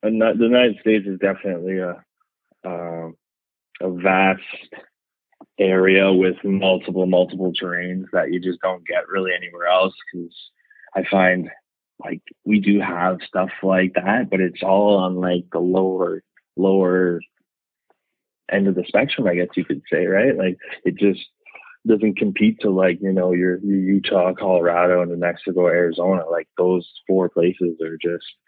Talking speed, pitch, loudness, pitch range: 155 wpm, 95 Hz, -19 LUFS, 90-95 Hz